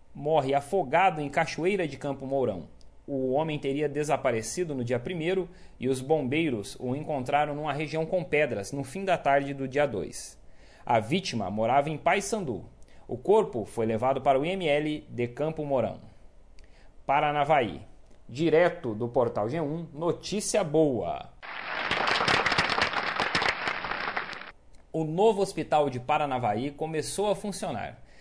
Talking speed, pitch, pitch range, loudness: 130 wpm, 150 Hz, 130-165 Hz, -28 LUFS